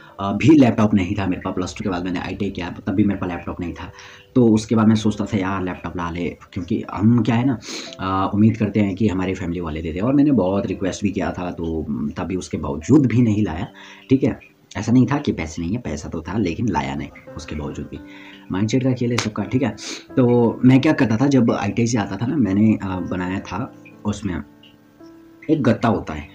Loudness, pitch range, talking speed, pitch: -20 LUFS, 90-115 Hz, 240 wpm, 100 Hz